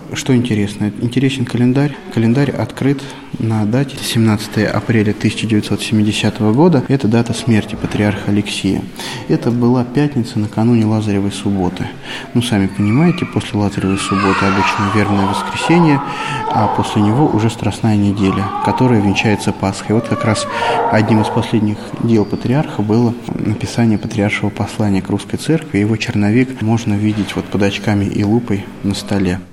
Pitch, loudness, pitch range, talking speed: 110 Hz, -15 LUFS, 100-120 Hz, 135 wpm